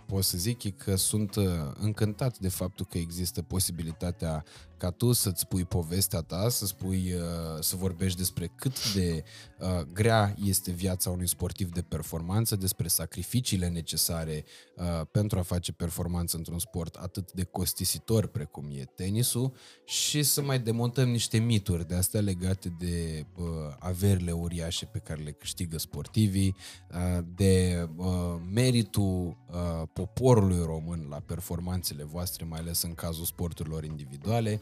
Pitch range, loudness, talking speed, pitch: 85-100 Hz, -30 LUFS, 140 wpm, 90 Hz